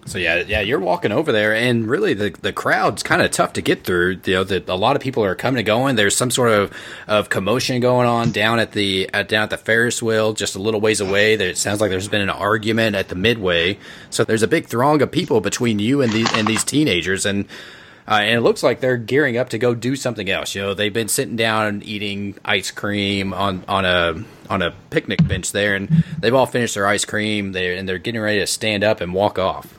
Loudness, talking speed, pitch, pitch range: -18 LUFS, 250 wpm, 105 Hz, 100-115 Hz